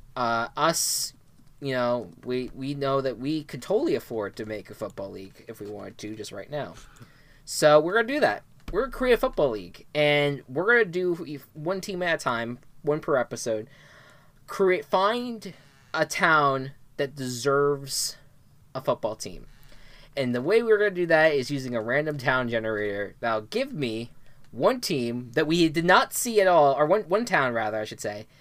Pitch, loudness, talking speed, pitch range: 140 Hz, -25 LUFS, 190 wpm, 120-160 Hz